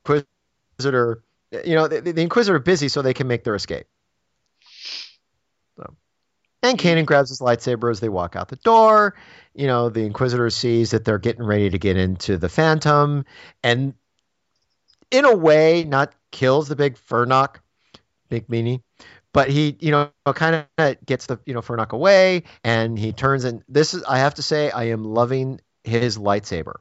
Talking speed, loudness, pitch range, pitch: 175 wpm, -19 LUFS, 115-150 Hz, 130 Hz